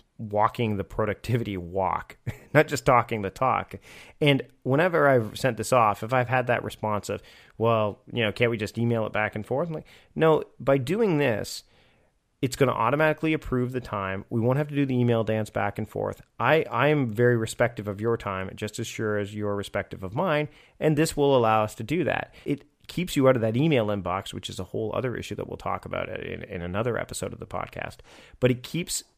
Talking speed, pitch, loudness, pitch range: 220 wpm, 120 Hz, -26 LUFS, 105-135 Hz